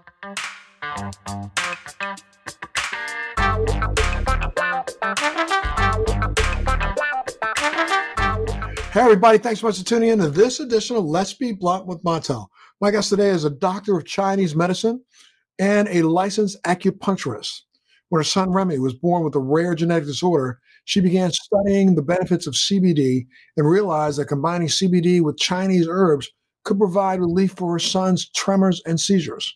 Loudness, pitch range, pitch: -20 LUFS, 150-200 Hz, 180 Hz